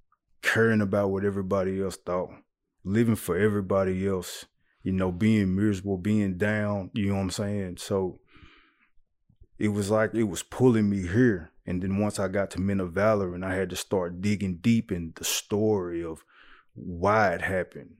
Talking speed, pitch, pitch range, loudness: 175 wpm, 100 Hz, 95-105 Hz, -27 LUFS